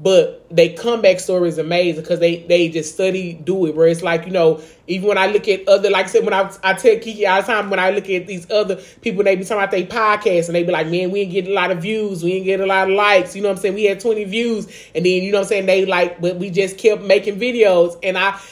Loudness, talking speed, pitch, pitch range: -17 LUFS, 300 wpm, 190 Hz, 180-205 Hz